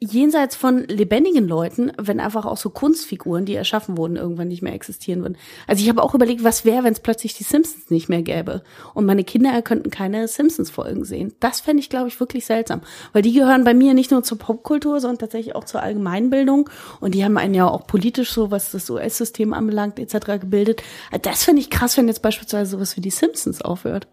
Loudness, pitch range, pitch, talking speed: -19 LUFS, 205-255 Hz, 225 Hz, 215 wpm